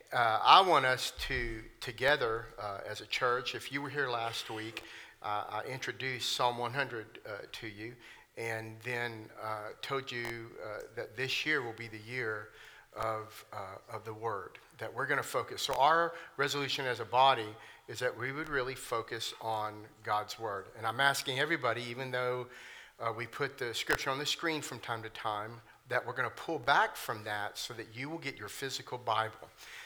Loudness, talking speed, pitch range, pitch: -34 LUFS, 195 wpm, 110-130 Hz, 120 Hz